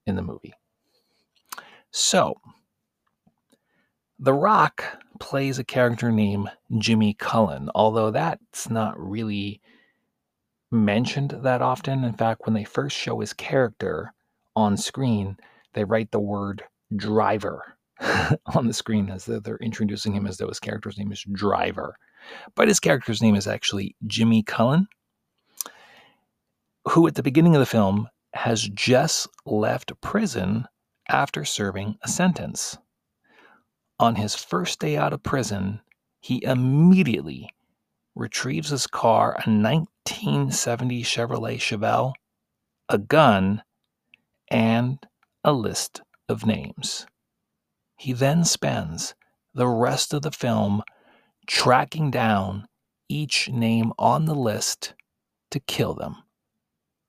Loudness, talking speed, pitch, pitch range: -23 LUFS, 120 wpm, 115 Hz, 105-130 Hz